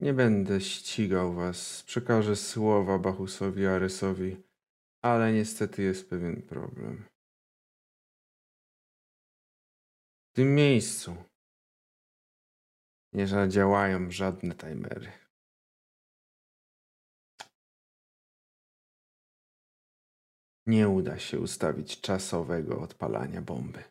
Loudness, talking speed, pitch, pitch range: -29 LUFS, 70 wpm, 95 Hz, 95-110 Hz